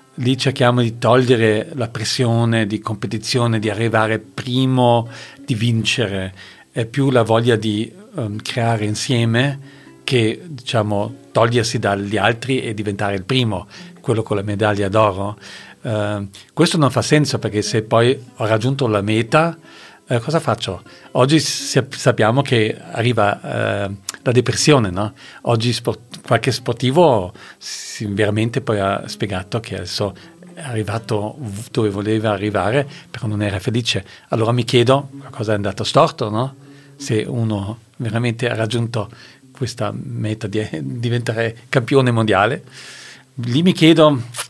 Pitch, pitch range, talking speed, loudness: 115 Hz, 110-130 Hz, 135 wpm, -18 LUFS